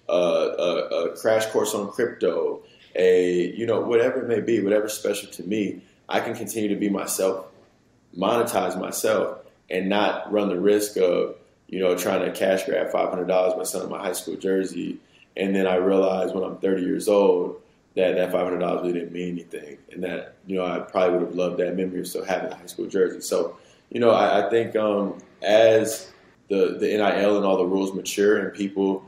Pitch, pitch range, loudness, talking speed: 100 Hz, 90-115 Hz, -23 LUFS, 200 wpm